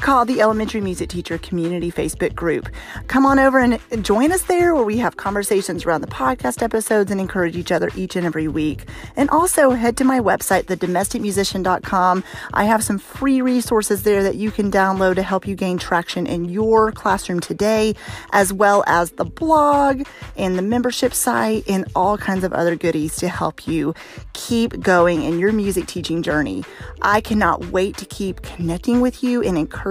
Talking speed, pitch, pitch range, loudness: 185 wpm, 200 Hz, 175-230 Hz, -19 LUFS